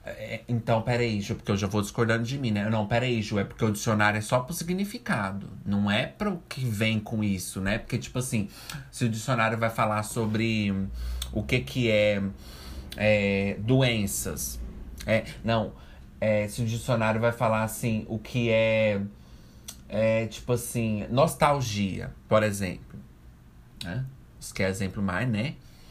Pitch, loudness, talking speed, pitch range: 110 Hz, -27 LUFS, 160 wpm, 100-120 Hz